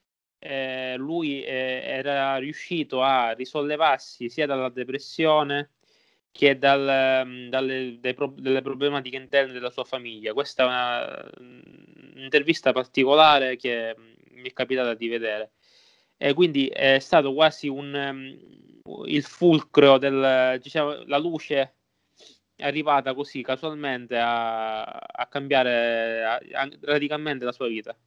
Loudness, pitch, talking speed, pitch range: -24 LUFS, 135 Hz, 125 wpm, 125-145 Hz